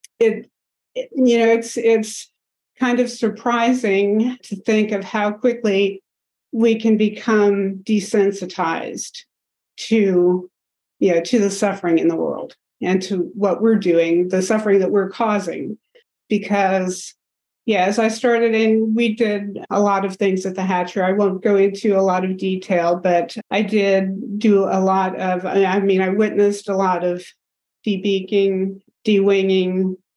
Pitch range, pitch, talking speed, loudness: 190-220 Hz, 200 Hz, 150 wpm, -18 LUFS